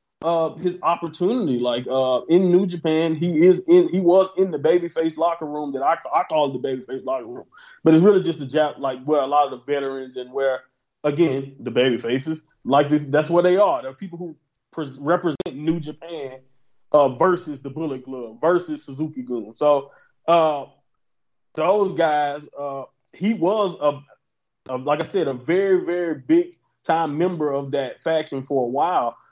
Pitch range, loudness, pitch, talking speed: 135-170 Hz, -21 LUFS, 150 Hz, 190 wpm